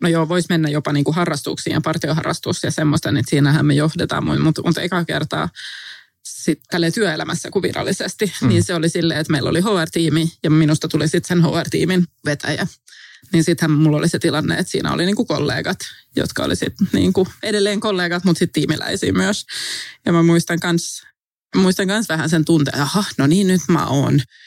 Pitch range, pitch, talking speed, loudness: 155-175 Hz, 165 Hz, 180 wpm, -18 LUFS